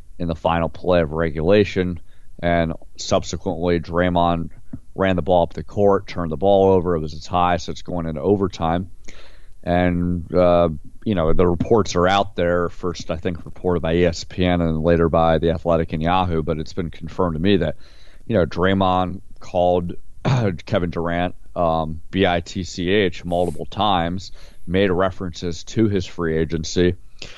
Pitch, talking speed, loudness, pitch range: 90 Hz, 160 wpm, -20 LUFS, 85-95 Hz